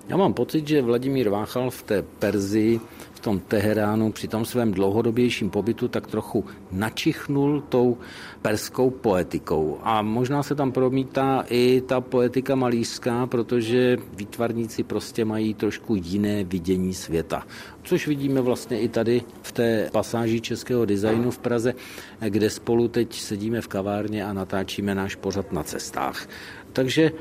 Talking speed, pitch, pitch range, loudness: 145 wpm, 115 Hz, 105-125 Hz, -24 LUFS